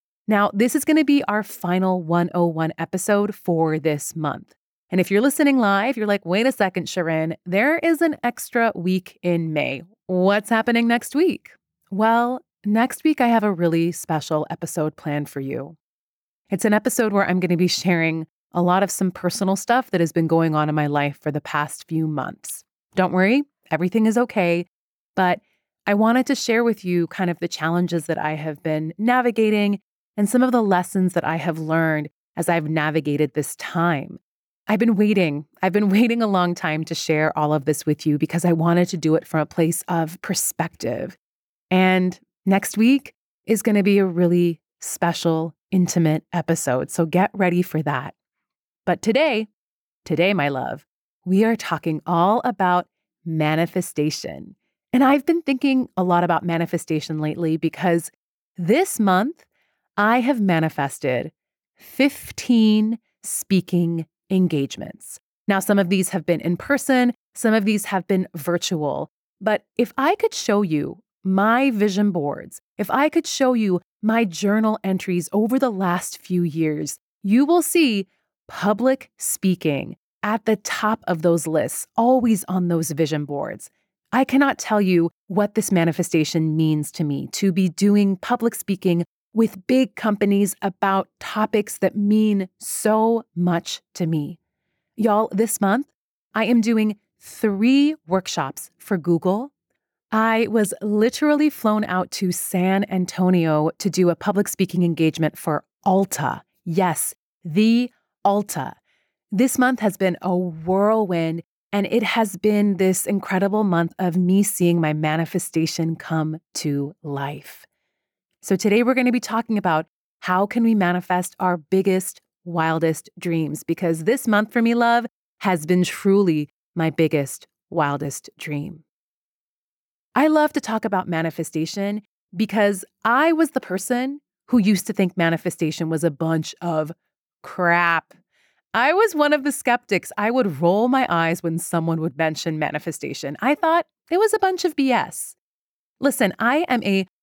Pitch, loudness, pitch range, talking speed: 185 Hz, -21 LUFS, 165-220 Hz, 160 wpm